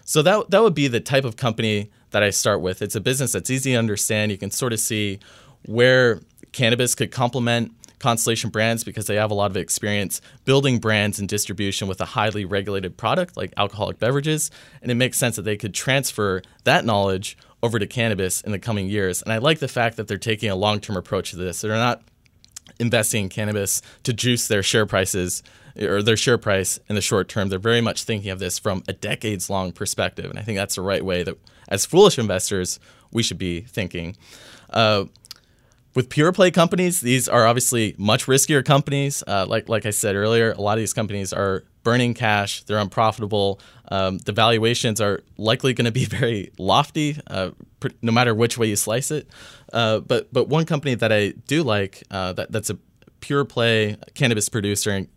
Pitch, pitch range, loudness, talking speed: 110 Hz, 100-120 Hz, -21 LUFS, 205 wpm